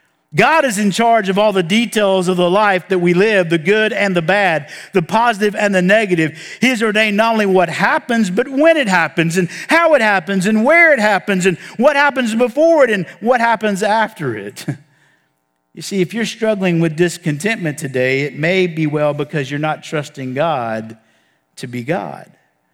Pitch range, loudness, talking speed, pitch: 155-220 Hz, -14 LUFS, 195 wpm, 190 Hz